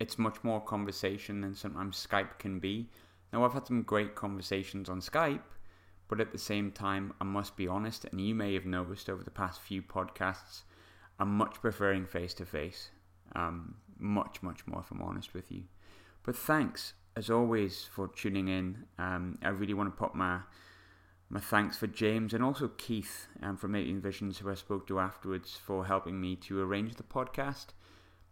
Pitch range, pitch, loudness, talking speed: 95-105 Hz, 95 Hz, -36 LUFS, 185 wpm